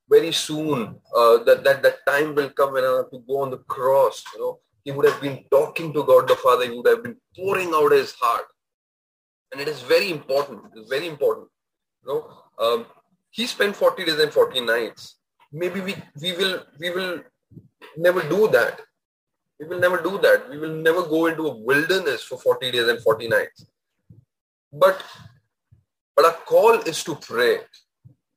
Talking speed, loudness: 190 wpm, -21 LUFS